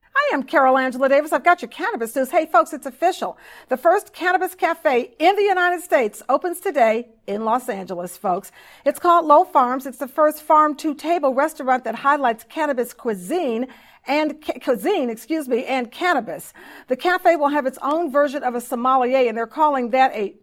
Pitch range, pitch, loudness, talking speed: 245-320 Hz, 280 Hz, -20 LUFS, 190 wpm